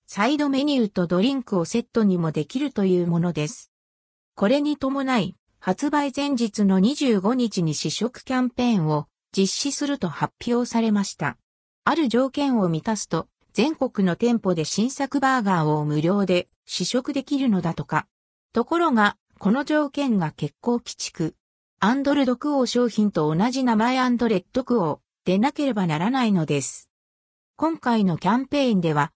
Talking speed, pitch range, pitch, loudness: 320 characters per minute, 175-260 Hz, 225 Hz, -23 LUFS